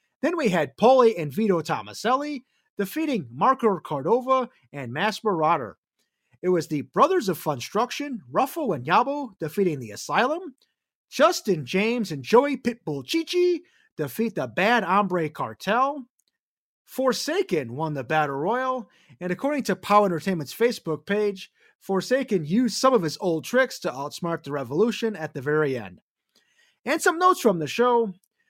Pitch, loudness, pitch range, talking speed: 210 Hz, -24 LUFS, 160-260 Hz, 145 wpm